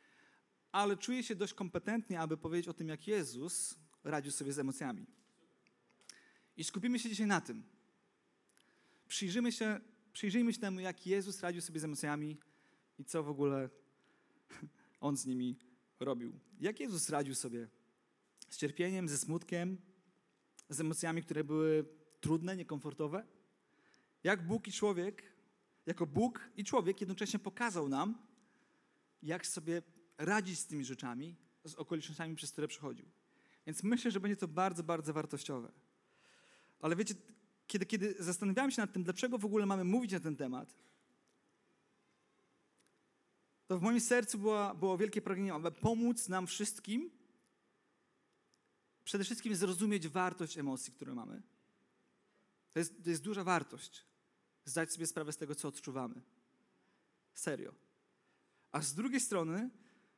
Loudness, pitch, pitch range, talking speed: -39 LUFS, 185 Hz, 155-210 Hz, 135 wpm